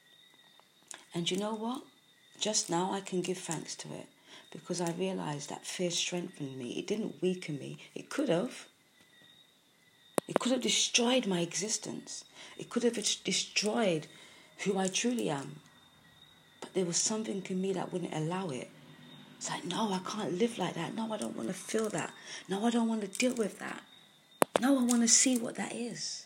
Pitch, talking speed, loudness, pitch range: 190 Hz, 185 wpm, -33 LUFS, 180-225 Hz